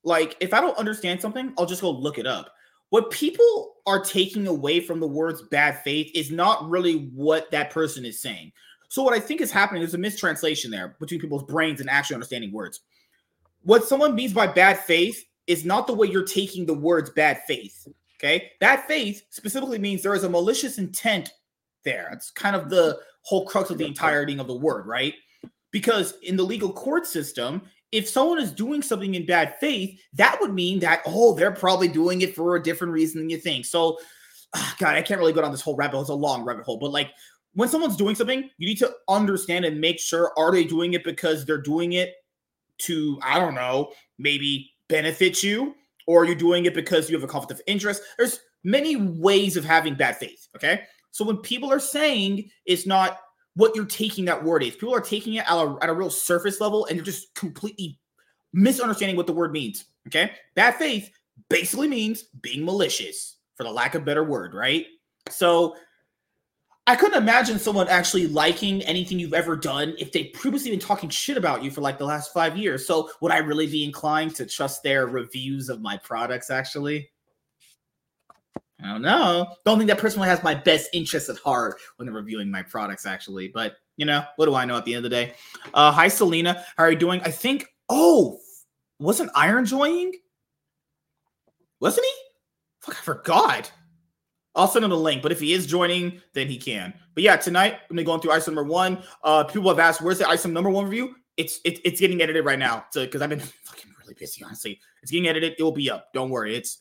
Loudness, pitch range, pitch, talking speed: -23 LUFS, 155-210 Hz, 175 Hz, 215 wpm